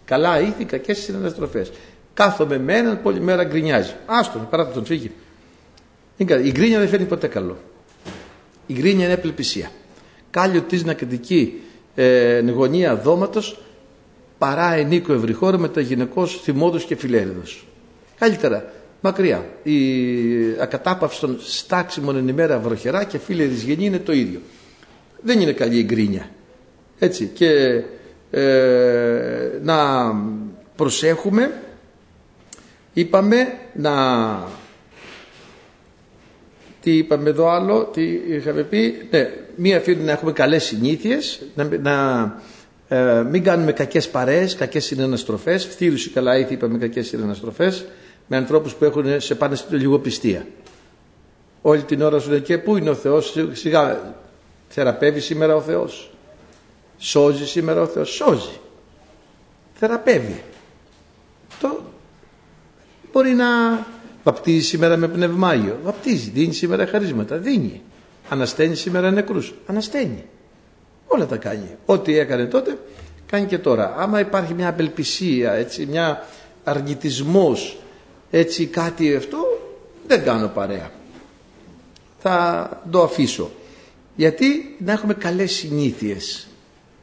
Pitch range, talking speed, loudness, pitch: 130-185 Hz, 120 wpm, -19 LUFS, 160 Hz